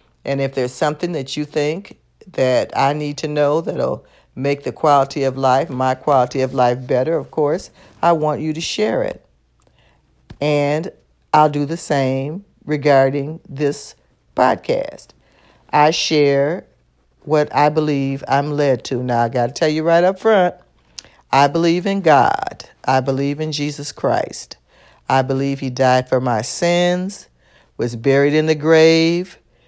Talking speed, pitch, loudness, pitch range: 155 wpm, 145 Hz, -17 LUFS, 130-155 Hz